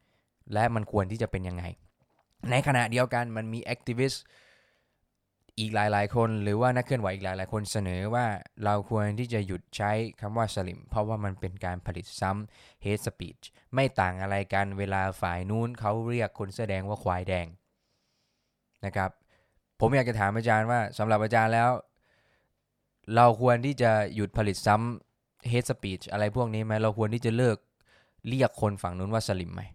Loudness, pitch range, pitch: -29 LUFS, 95-120 Hz, 105 Hz